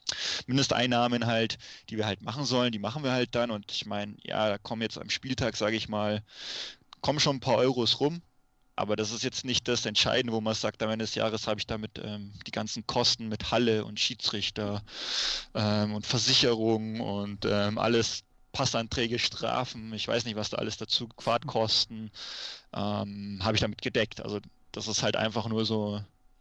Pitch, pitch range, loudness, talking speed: 110 Hz, 105-120 Hz, -29 LUFS, 190 wpm